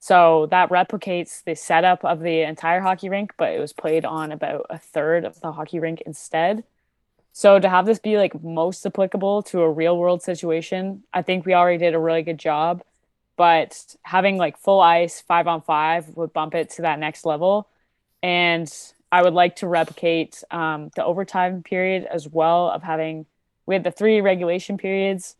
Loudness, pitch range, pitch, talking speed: -20 LUFS, 160-185 Hz, 175 Hz, 190 wpm